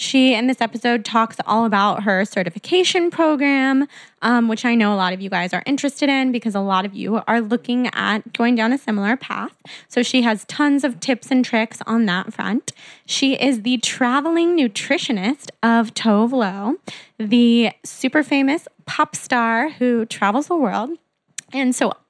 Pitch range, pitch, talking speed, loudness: 220-270 Hz, 240 Hz, 175 wpm, -19 LUFS